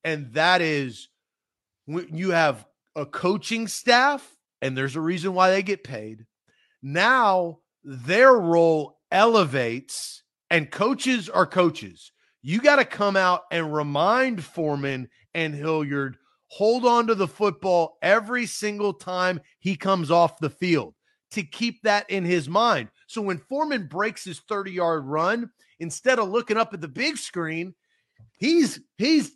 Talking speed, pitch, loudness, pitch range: 145 wpm, 180 Hz, -23 LUFS, 160-215 Hz